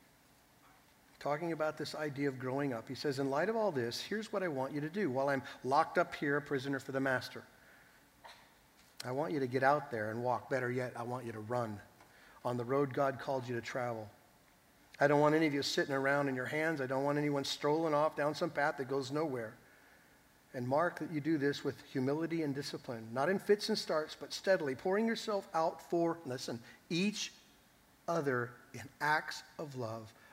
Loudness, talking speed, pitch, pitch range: -36 LUFS, 210 wpm, 140 Hz, 130-160 Hz